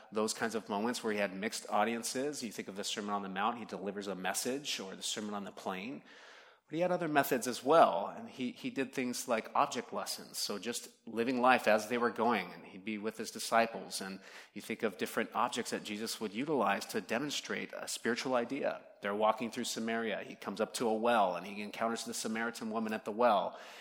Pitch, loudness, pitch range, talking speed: 115 Hz, -35 LUFS, 105-130 Hz, 225 wpm